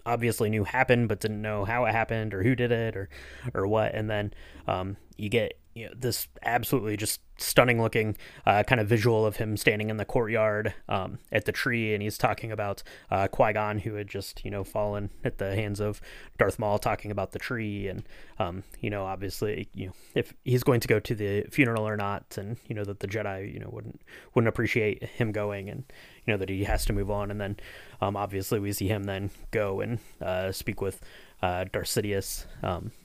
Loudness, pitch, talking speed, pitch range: -29 LUFS, 105 Hz, 215 wpm, 100-115 Hz